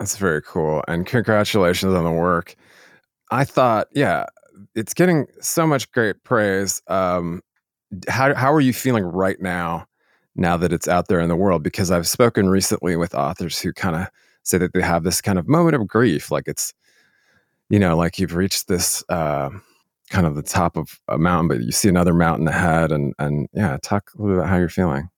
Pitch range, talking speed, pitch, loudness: 85-105 Hz, 205 wpm, 90 Hz, -20 LUFS